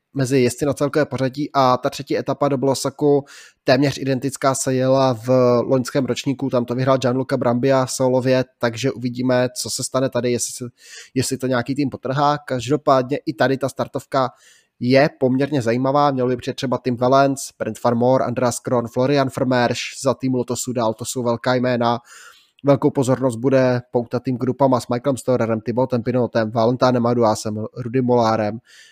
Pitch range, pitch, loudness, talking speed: 120-135 Hz, 130 Hz, -19 LUFS, 170 wpm